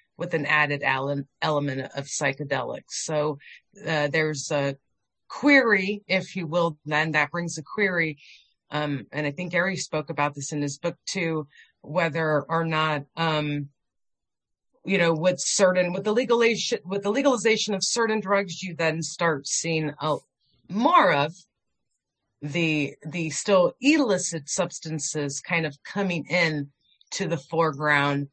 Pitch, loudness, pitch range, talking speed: 160 Hz, -25 LUFS, 145-185 Hz, 140 wpm